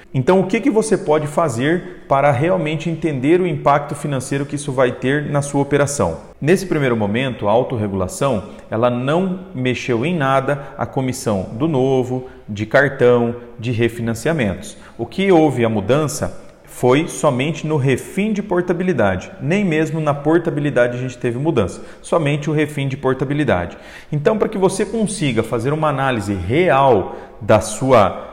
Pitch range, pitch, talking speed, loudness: 125-165 Hz, 140 Hz, 155 wpm, -18 LUFS